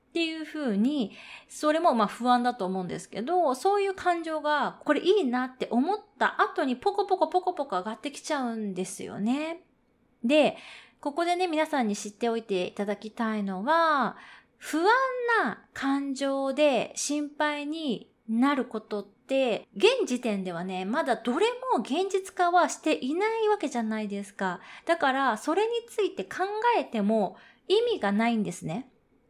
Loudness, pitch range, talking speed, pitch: -28 LUFS, 225-340 Hz, 310 characters per minute, 275 Hz